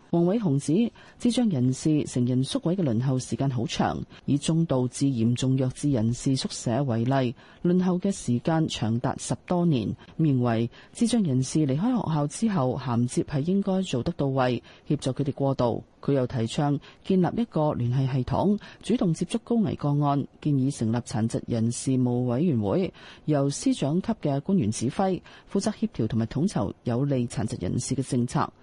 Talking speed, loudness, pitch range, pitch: 270 characters per minute, -26 LUFS, 125-170 Hz, 135 Hz